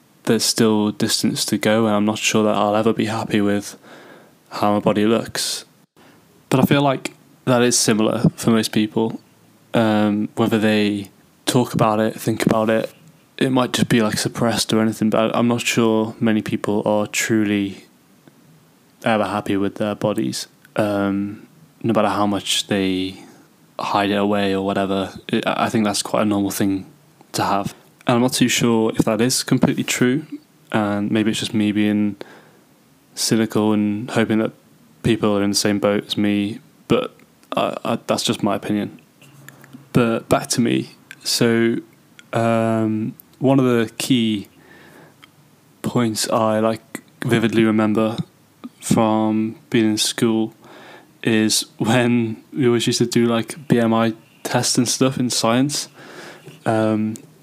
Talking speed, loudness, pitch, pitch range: 155 wpm, -19 LUFS, 110 Hz, 105-115 Hz